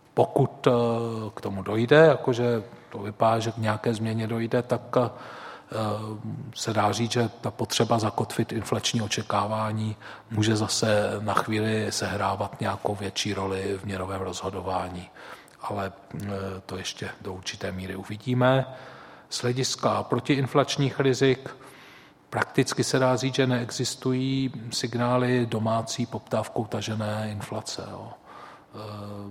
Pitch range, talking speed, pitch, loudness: 105-125 Hz, 115 wpm, 115 Hz, -26 LUFS